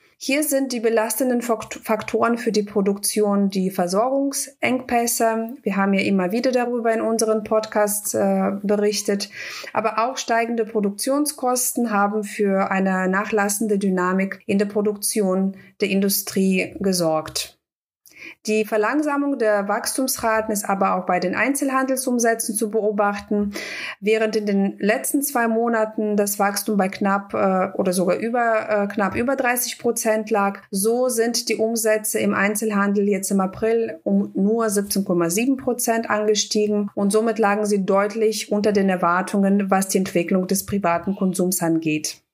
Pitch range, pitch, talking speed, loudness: 195-230 Hz, 210 Hz, 135 wpm, -21 LUFS